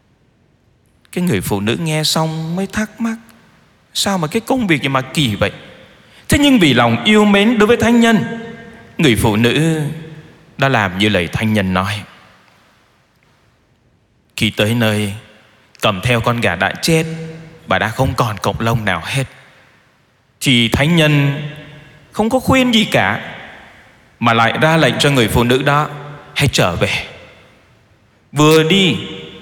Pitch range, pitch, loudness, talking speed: 110-160 Hz, 140 Hz, -14 LUFS, 155 wpm